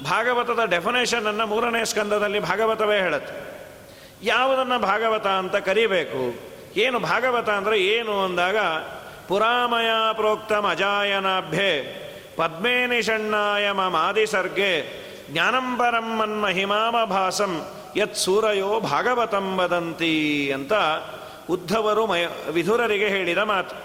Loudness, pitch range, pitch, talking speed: -22 LUFS, 190-230 Hz, 210 Hz, 85 wpm